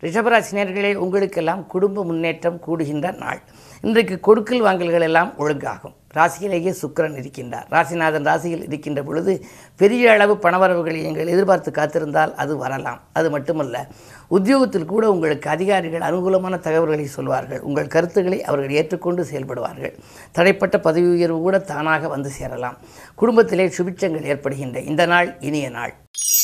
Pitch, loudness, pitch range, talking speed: 170 Hz, -19 LUFS, 150-190 Hz, 120 wpm